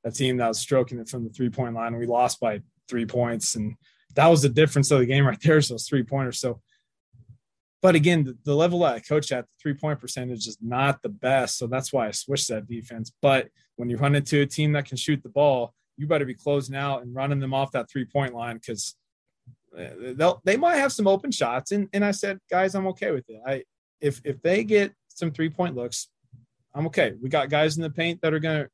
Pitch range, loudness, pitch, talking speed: 120-155 Hz, -24 LUFS, 135 Hz, 235 wpm